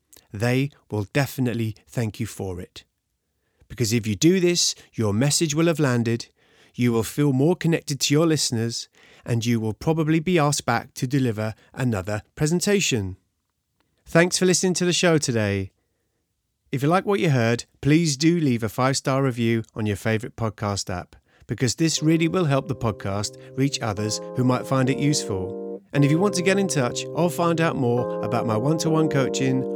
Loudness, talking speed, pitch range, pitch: -23 LUFS, 190 wpm, 110-160 Hz, 130 Hz